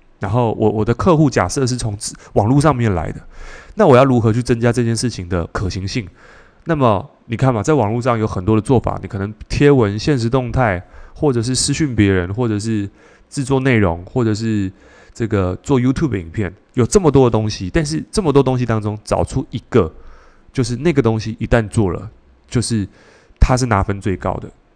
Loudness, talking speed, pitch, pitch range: -17 LUFS, 305 characters per minute, 115 Hz, 105-130 Hz